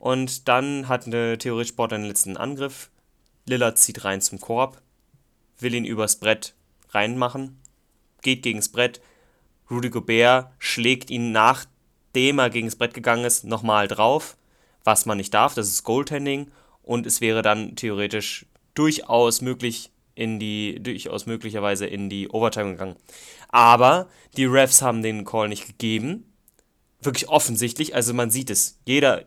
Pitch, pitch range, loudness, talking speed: 120 Hz, 110-125 Hz, -21 LUFS, 150 wpm